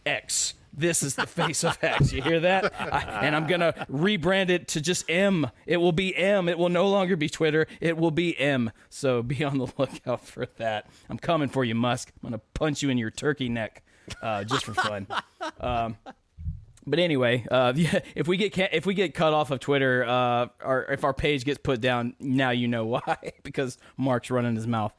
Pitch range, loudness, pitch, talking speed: 125-170 Hz, -26 LUFS, 140 Hz, 210 wpm